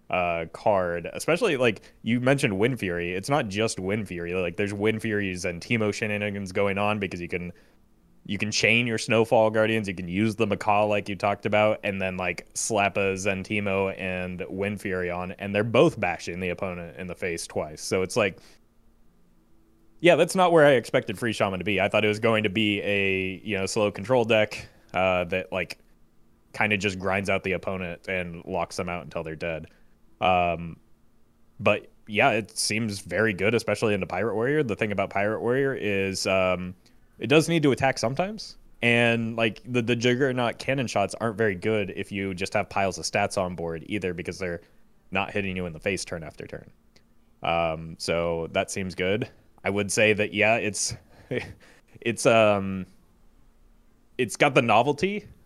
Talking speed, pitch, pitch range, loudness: 190 wpm, 100 Hz, 90-110 Hz, -25 LUFS